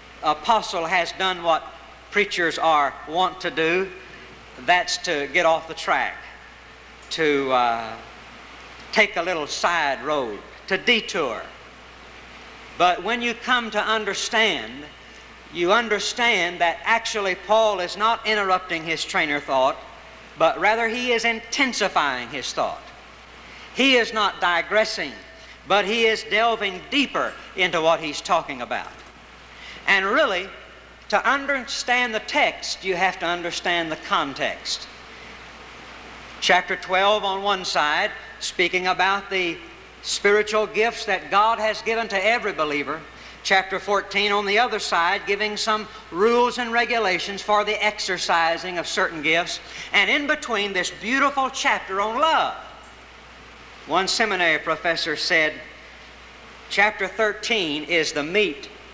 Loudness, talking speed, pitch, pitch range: -21 LUFS, 125 wpm, 195 Hz, 170-220 Hz